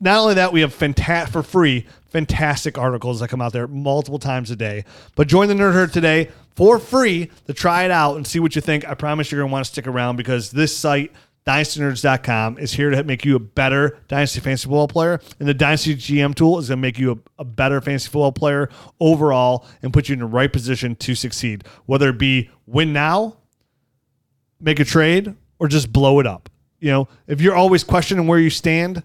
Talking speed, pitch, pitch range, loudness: 215 wpm, 140 Hz, 130-160 Hz, -18 LUFS